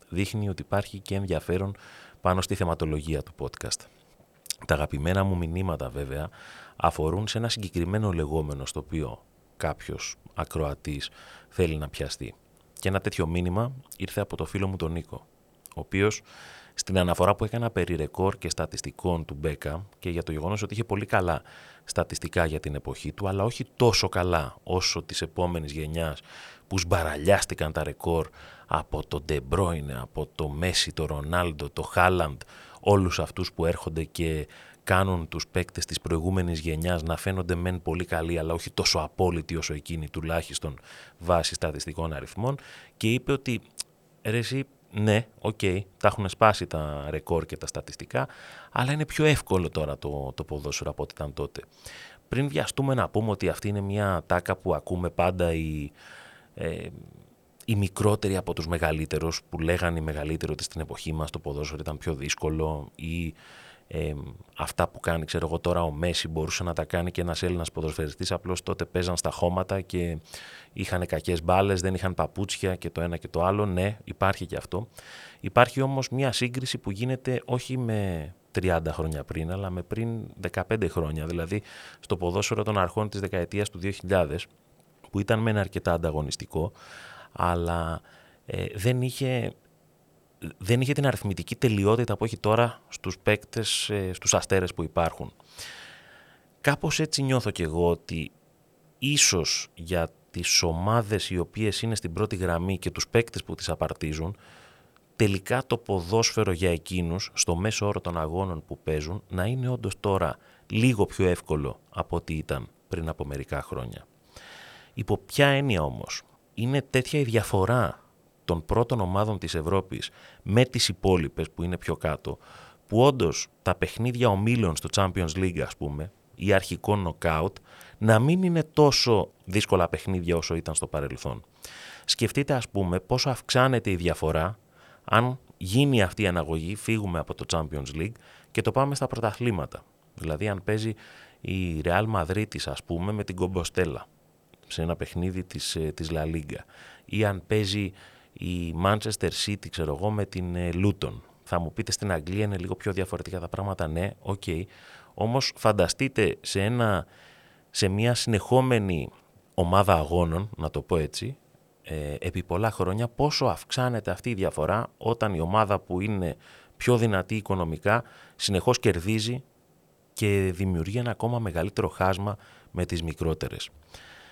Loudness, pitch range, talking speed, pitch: -28 LUFS, 80-105 Hz, 155 wpm, 90 Hz